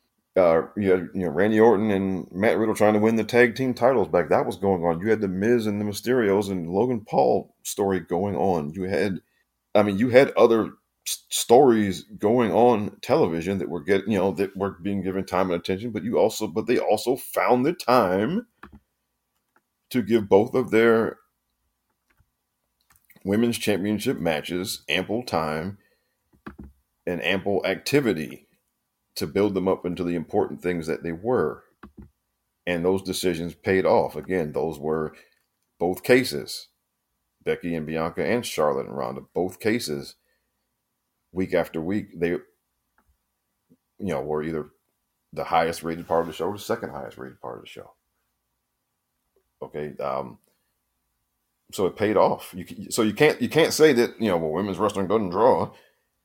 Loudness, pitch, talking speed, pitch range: -23 LUFS, 95 Hz, 165 wpm, 85-110 Hz